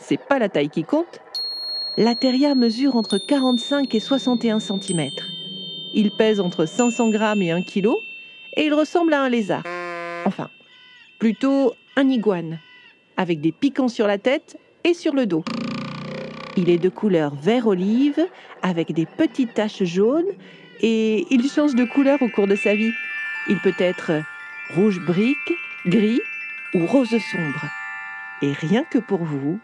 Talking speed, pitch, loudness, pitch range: 155 wpm, 215 Hz, -21 LUFS, 180-270 Hz